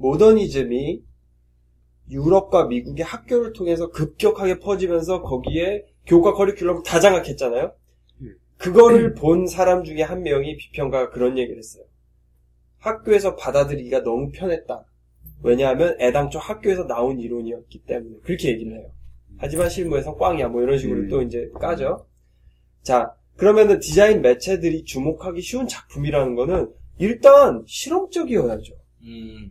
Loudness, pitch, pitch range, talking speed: -19 LUFS, 150 Hz, 120-185 Hz, 335 characters per minute